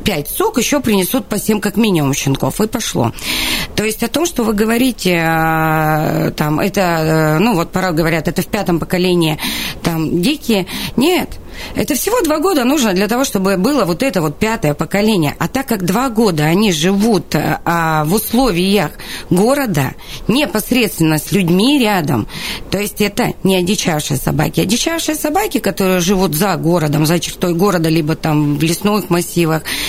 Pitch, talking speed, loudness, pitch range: 190 Hz, 160 wpm, -15 LUFS, 165-225 Hz